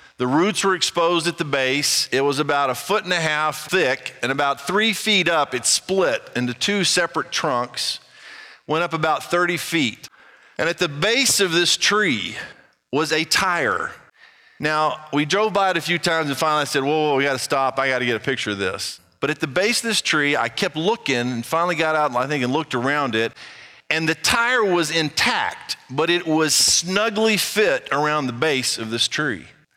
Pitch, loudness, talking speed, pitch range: 155 Hz, -20 LUFS, 205 wpm, 135-175 Hz